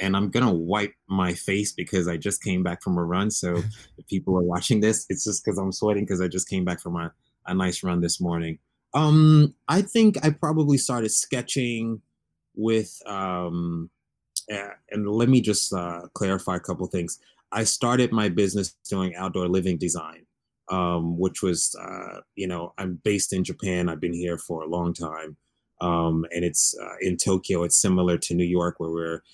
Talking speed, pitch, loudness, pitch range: 190 wpm, 95 Hz, -24 LUFS, 85-105 Hz